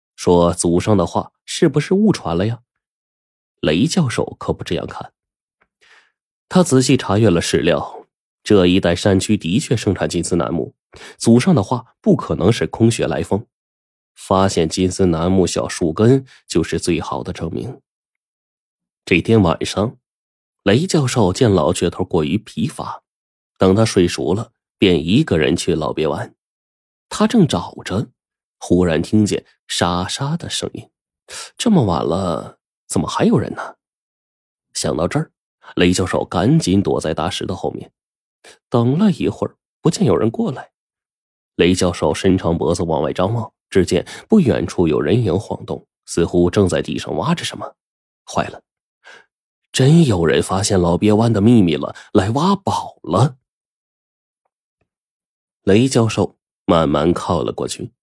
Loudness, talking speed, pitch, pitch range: -17 LUFS, 210 characters per minute, 95 Hz, 85-115 Hz